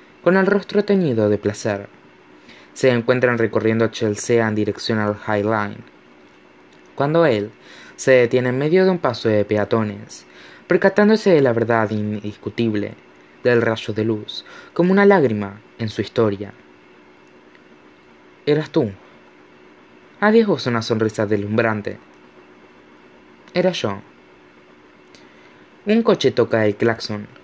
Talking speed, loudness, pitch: 120 wpm, -19 LUFS, 110 Hz